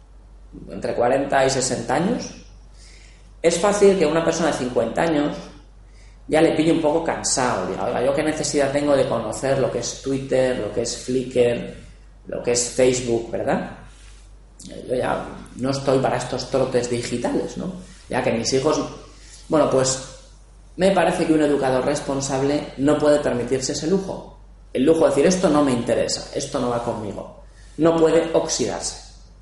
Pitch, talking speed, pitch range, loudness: 135 Hz, 165 wpm, 125-150 Hz, -21 LUFS